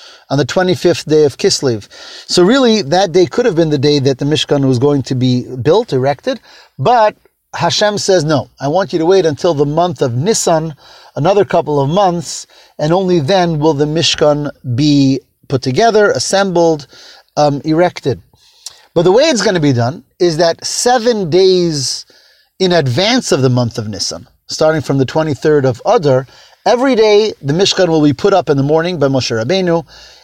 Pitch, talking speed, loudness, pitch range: 160 Hz, 185 wpm, -13 LUFS, 140-185 Hz